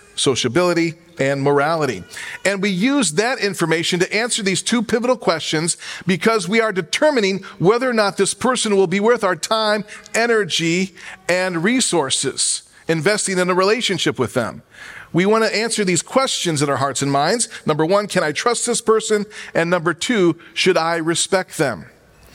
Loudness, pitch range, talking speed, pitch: -18 LUFS, 170-220 Hz, 165 wpm, 190 Hz